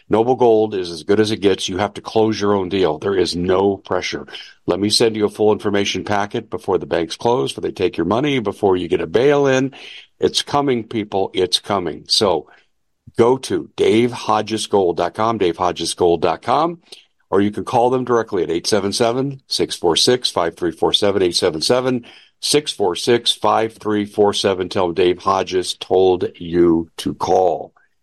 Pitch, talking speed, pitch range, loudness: 110 Hz, 150 wpm, 100-125 Hz, -18 LUFS